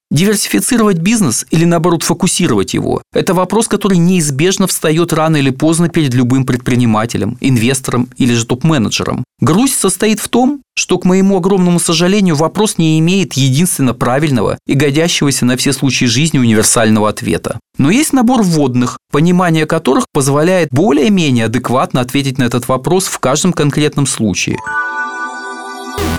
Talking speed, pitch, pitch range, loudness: 135 wpm, 160 Hz, 130-185 Hz, -12 LUFS